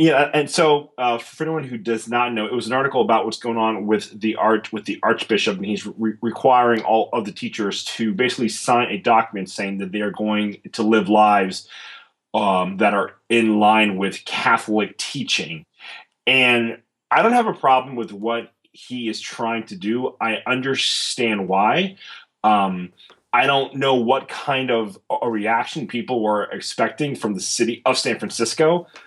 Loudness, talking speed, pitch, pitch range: -20 LUFS, 180 wpm, 115 Hz, 105-125 Hz